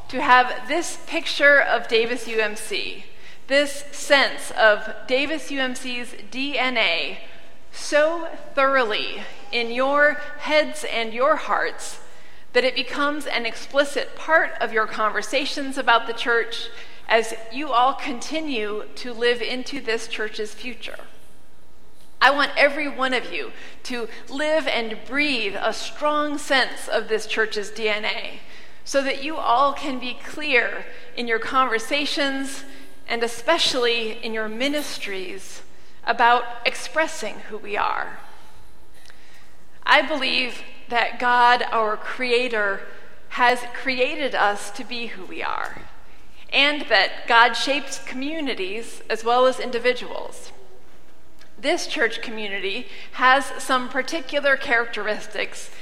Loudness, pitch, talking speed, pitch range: -22 LUFS, 255 Hz, 120 wpm, 230-285 Hz